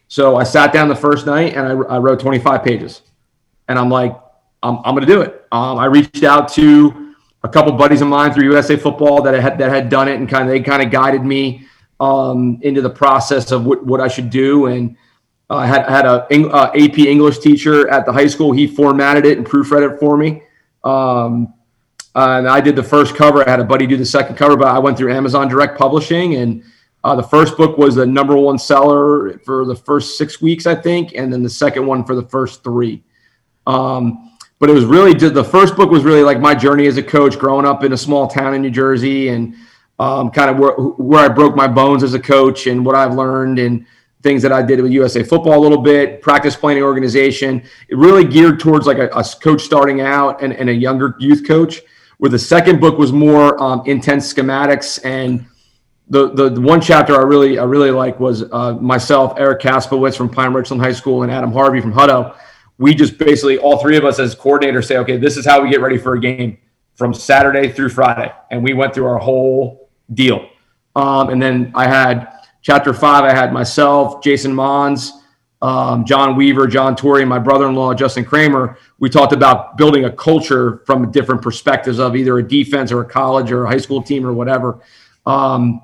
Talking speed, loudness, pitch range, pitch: 220 wpm, -12 LUFS, 130-145 Hz, 135 Hz